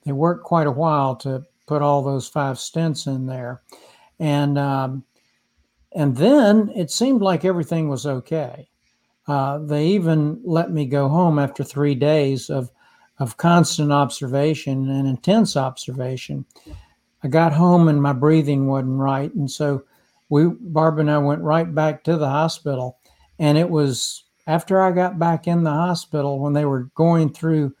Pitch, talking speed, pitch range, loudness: 150 Hz, 160 wpm, 135-165 Hz, -20 LUFS